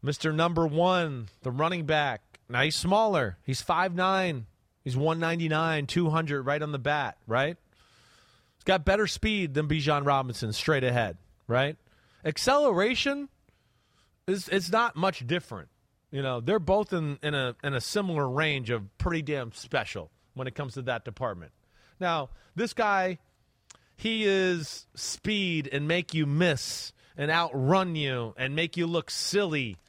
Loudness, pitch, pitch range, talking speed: -28 LUFS, 150 Hz, 130-180 Hz, 155 wpm